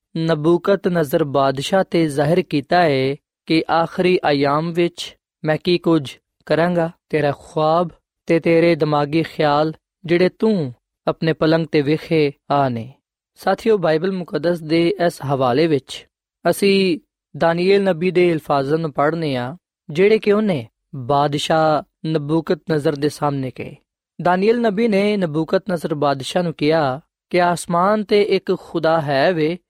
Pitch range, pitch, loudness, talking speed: 150-180 Hz, 165 Hz, -18 LUFS, 130 wpm